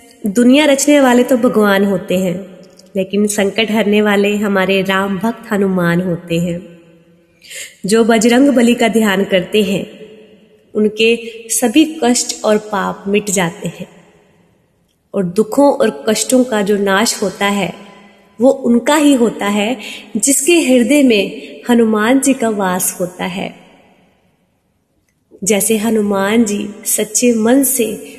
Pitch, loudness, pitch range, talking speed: 215 Hz, -13 LUFS, 195-235 Hz, 130 wpm